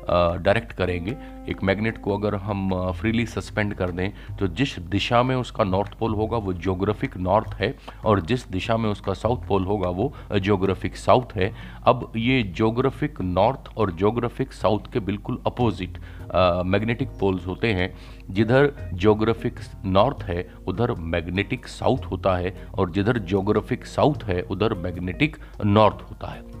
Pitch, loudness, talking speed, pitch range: 105 Hz, -24 LUFS, 160 wpm, 95-115 Hz